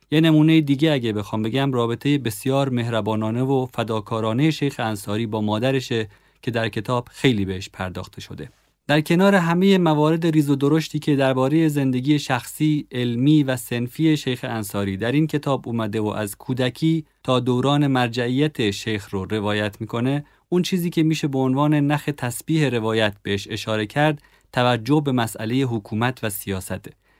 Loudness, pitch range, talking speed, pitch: -21 LUFS, 110-150 Hz, 155 wpm, 130 Hz